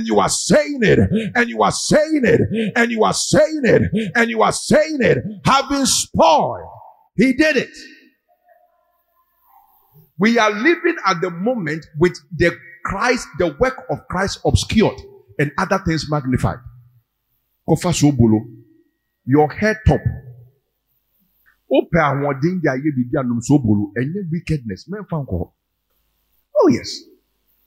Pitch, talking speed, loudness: 185 Hz, 110 wpm, -17 LUFS